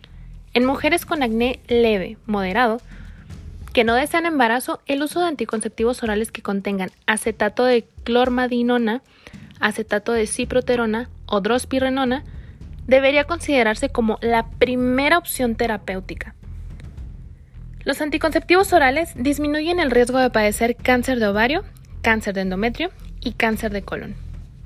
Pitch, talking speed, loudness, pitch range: 240 Hz, 120 wpm, -20 LUFS, 220-265 Hz